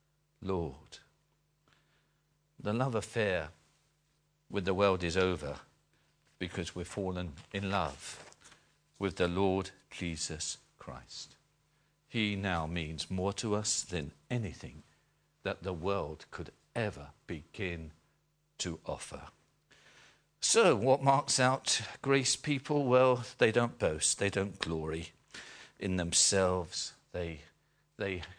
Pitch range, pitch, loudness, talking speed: 90-125 Hz, 95 Hz, -33 LUFS, 110 wpm